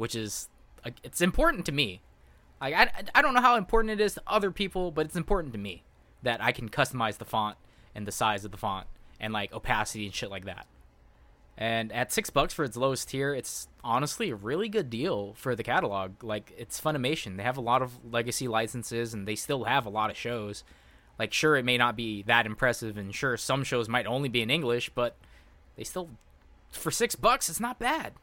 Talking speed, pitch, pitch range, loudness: 220 wpm, 120 Hz, 105-140 Hz, -29 LUFS